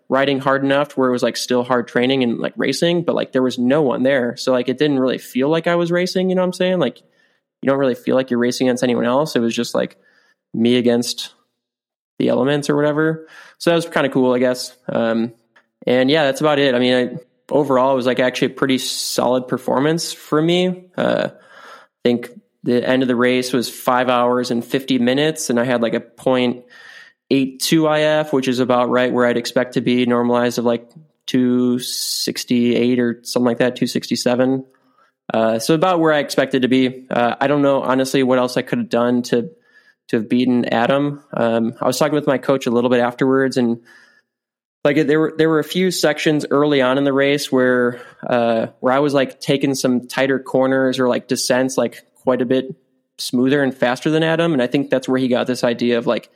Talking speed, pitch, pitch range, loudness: 220 wpm, 130 Hz, 125-140 Hz, -18 LUFS